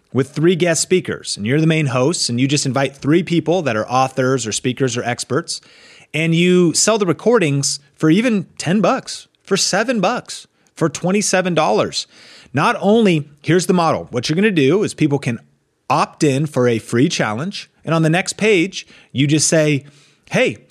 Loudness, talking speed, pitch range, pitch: -17 LUFS, 185 wpm, 135-180 Hz, 155 Hz